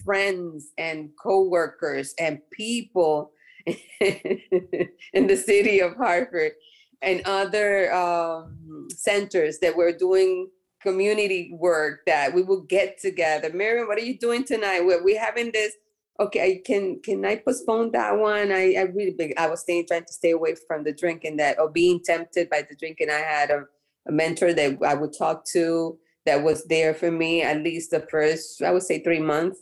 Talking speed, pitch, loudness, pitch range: 175 wpm, 175 Hz, -23 LUFS, 160-200 Hz